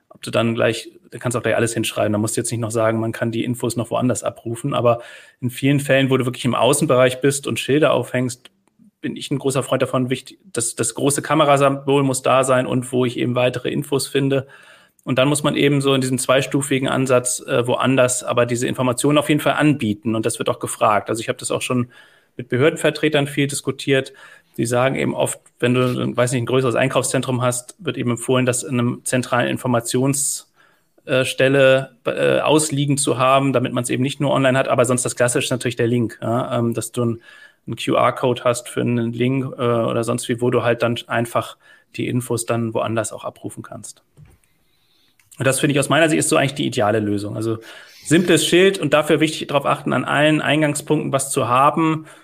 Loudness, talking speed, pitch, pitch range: -19 LUFS, 215 wpm, 130 Hz, 120-140 Hz